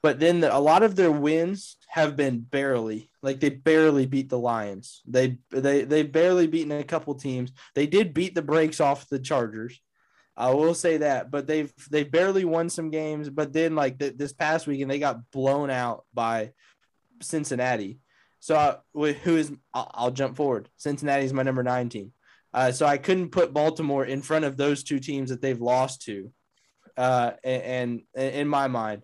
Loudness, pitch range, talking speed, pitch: -25 LUFS, 130-155 Hz, 195 wpm, 140 Hz